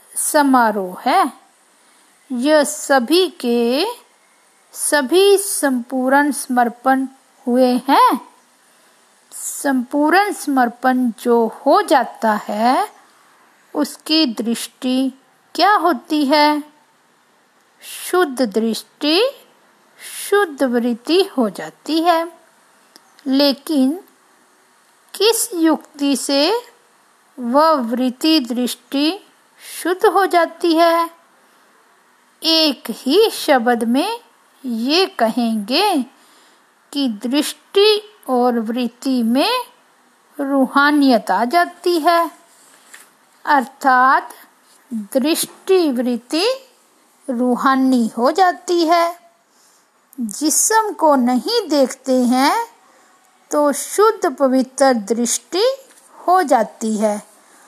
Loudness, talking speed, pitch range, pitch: -16 LUFS, 75 wpm, 250-345 Hz, 285 Hz